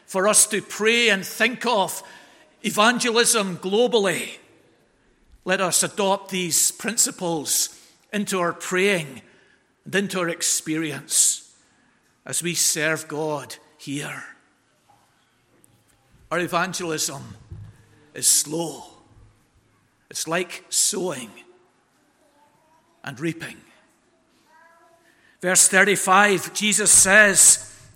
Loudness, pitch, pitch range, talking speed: -19 LUFS, 185 Hz, 160-215 Hz, 85 wpm